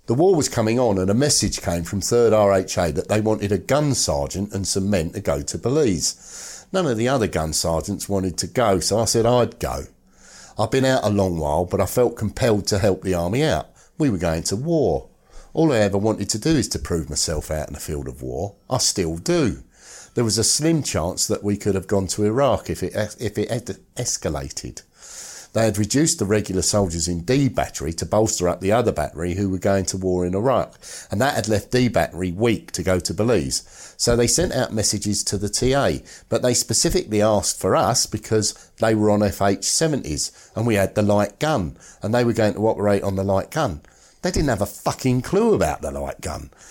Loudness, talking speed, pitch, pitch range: -21 LUFS, 225 wpm, 105 Hz, 95-115 Hz